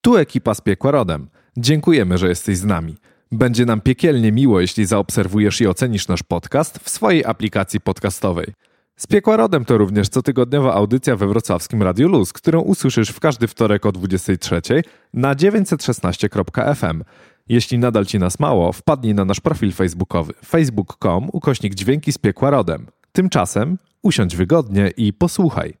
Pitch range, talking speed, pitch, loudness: 100-140 Hz, 150 wpm, 110 Hz, -17 LUFS